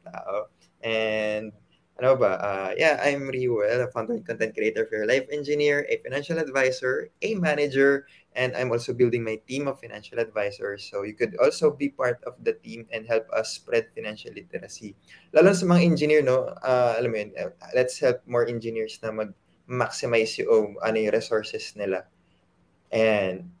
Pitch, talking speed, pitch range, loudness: 125 Hz, 170 wpm, 110-160 Hz, -25 LUFS